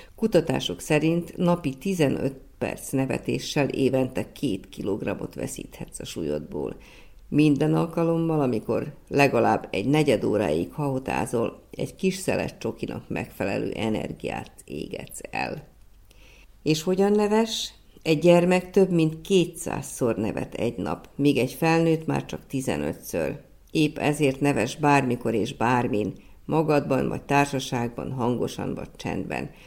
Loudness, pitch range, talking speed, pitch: -25 LUFS, 130-170 Hz, 115 wpm, 145 Hz